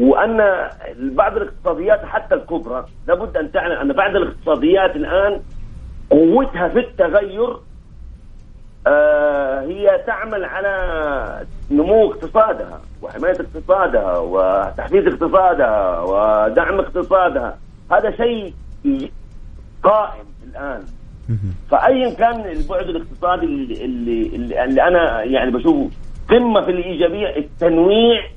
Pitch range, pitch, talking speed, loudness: 160-235 Hz, 190 Hz, 95 wpm, -17 LUFS